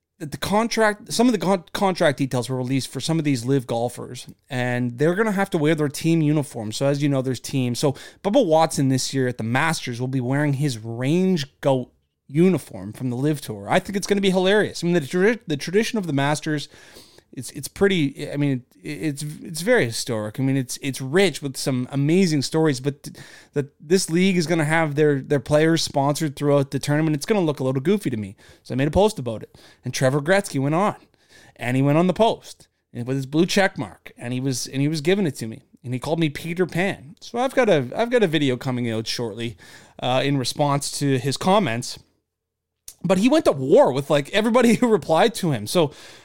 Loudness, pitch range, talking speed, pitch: -22 LUFS, 130-175 Hz, 230 wpm, 145 Hz